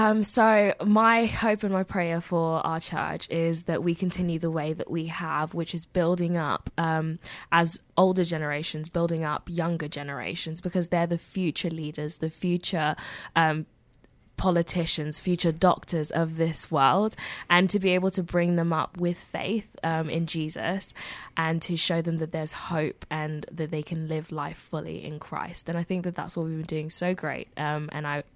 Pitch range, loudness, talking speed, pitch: 155-175 Hz, -27 LUFS, 185 wpm, 165 Hz